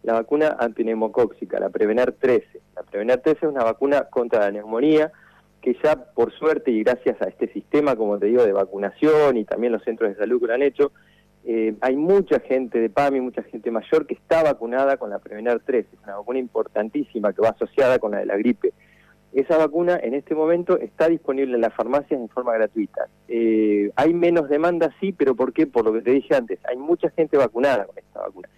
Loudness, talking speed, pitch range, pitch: -21 LUFS, 210 wpm, 115-160 Hz, 140 Hz